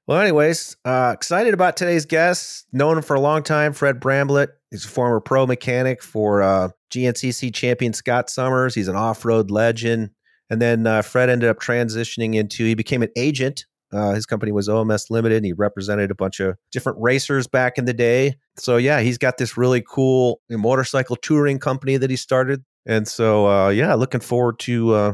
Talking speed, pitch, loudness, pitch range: 190 wpm, 125 Hz, -19 LUFS, 110-130 Hz